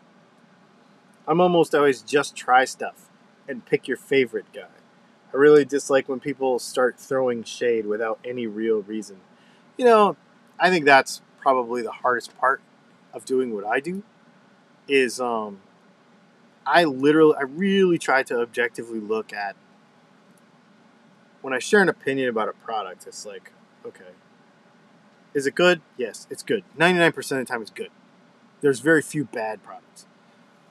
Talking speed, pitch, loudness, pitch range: 150 wpm, 200 Hz, -22 LUFS, 135-210 Hz